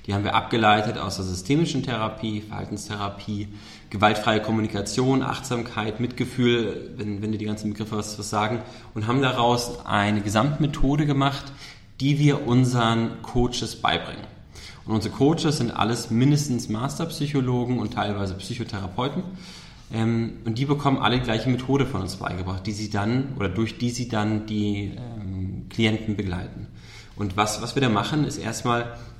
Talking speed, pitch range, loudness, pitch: 150 wpm, 105-125 Hz, -24 LUFS, 115 Hz